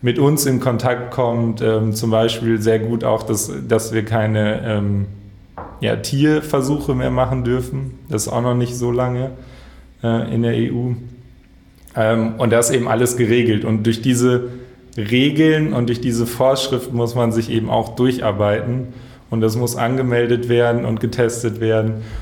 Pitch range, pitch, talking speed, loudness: 110-125 Hz, 120 Hz, 160 wpm, -18 LUFS